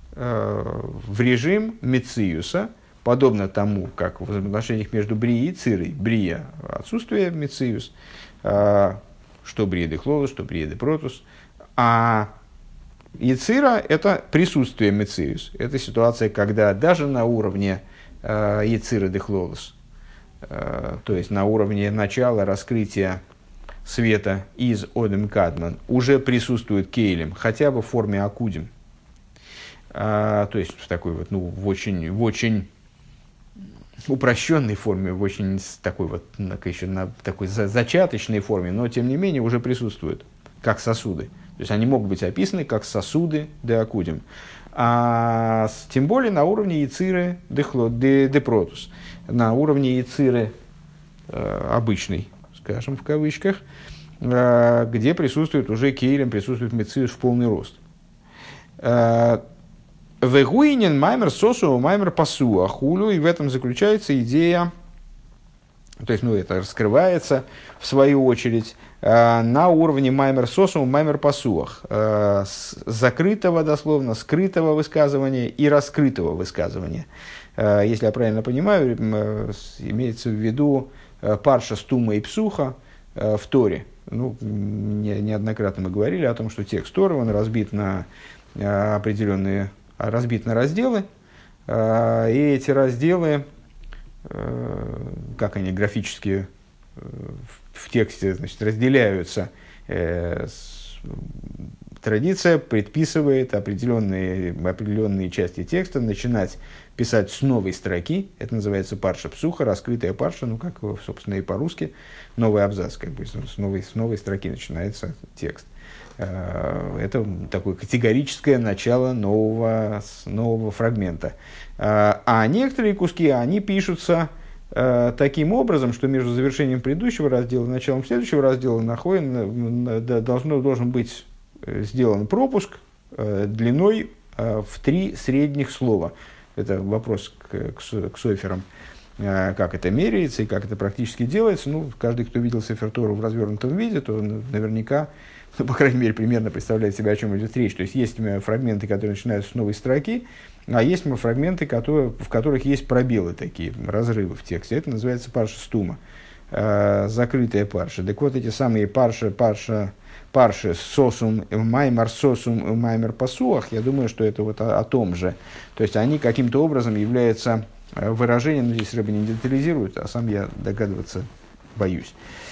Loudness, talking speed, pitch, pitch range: -22 LUFS, 125 wpm, 115 Hz, 105-135 Hz